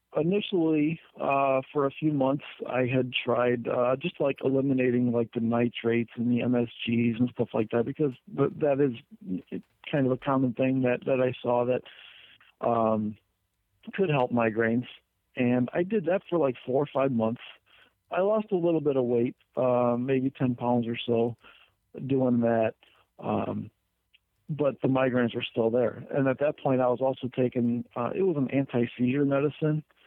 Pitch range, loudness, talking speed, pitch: 120-140 Hz, -27 LUFS, 170 wpm, 125 Hz